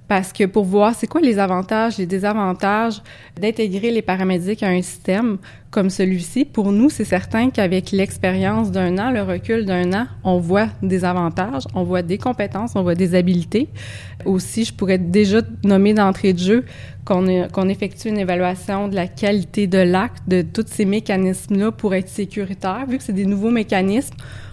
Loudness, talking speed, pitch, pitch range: -19 LUFS, 185 wpm, 195 Hz, 185-215 Hz